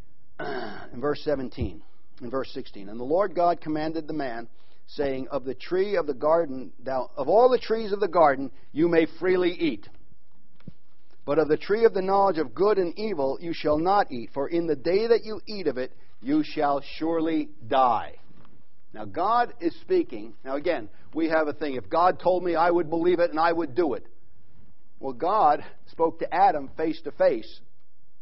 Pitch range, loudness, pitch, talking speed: 140-205 Hz, -25 LUFS, 165 Hz, 195 wpm